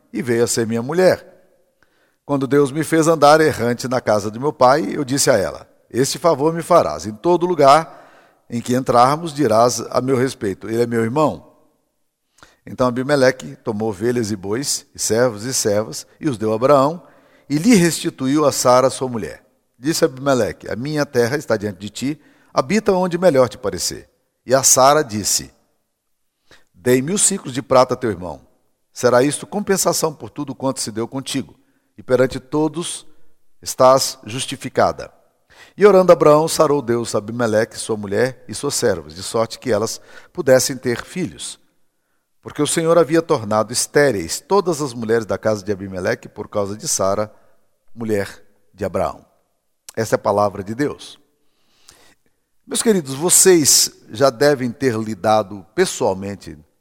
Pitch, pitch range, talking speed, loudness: 130 Hz, 115-155 Hz, 165 wpm, -17 LUFS